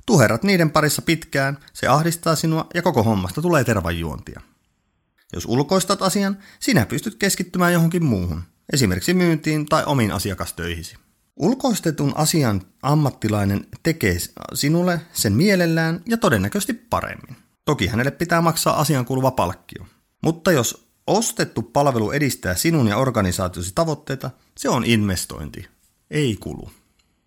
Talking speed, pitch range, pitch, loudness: 125 wpm, 110-170 Hz, 145 Hz, -20 LUFS